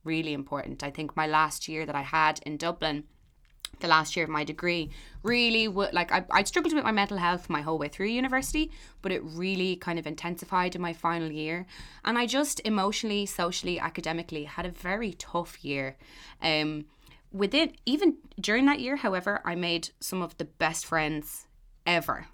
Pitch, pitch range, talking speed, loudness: 175 Hz, 155-205 Hz, 185 wpm, -29 LUFS